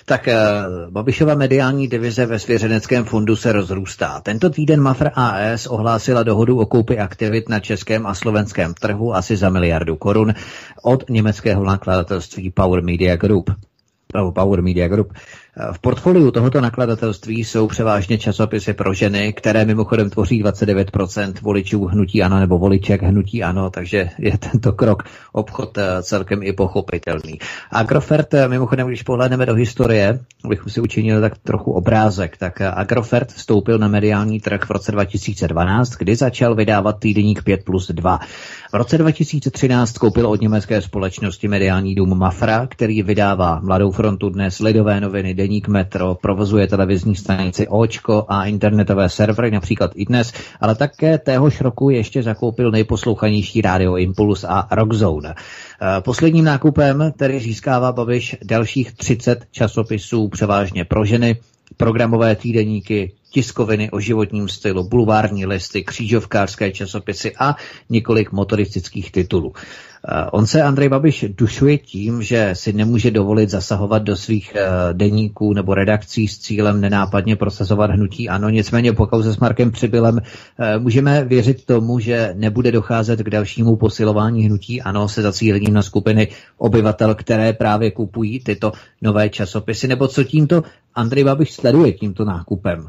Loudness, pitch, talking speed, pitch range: -17 LUFS, 110 Hz, 140 wpm, 100-120 Hz